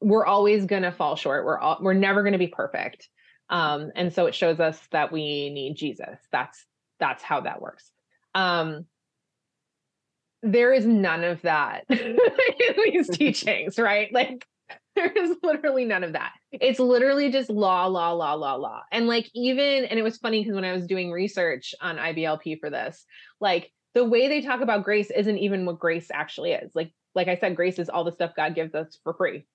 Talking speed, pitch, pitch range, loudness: 195 wpm, 200 Hz, 170-250 Hz, -24 LUFS